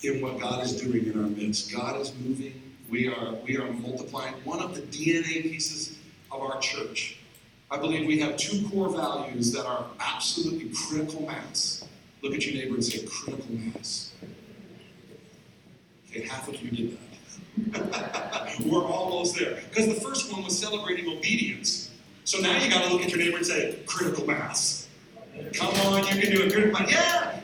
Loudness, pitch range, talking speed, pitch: -28 LUFS, 125-195 Hz, 175 wpm, 155 Hz